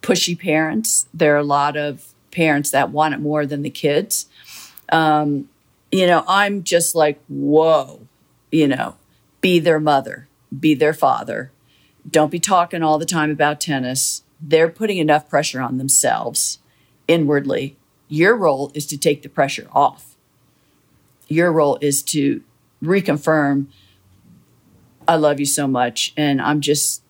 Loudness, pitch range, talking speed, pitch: -18 LUFS, 140-160 Hz, 145 wpm, 150 Hz